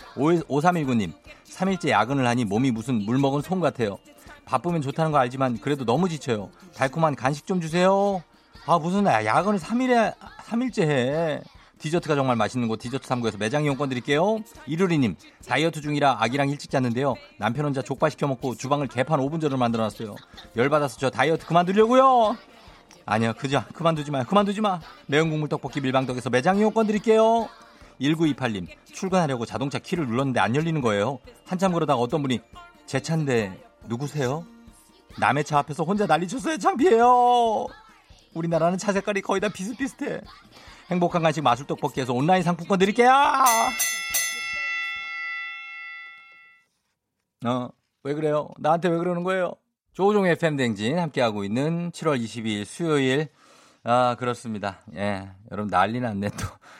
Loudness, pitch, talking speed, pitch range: -24 LUFS, 145 Hz, 345 characters per minute, 120-180 Hz